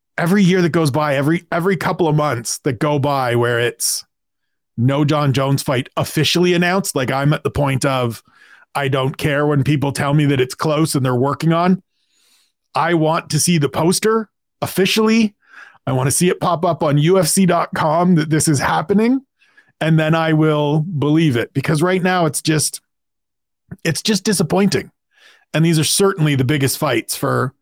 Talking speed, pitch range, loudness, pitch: 180 wpm, 140-180 Hz, -17 LUFS, 155 Hz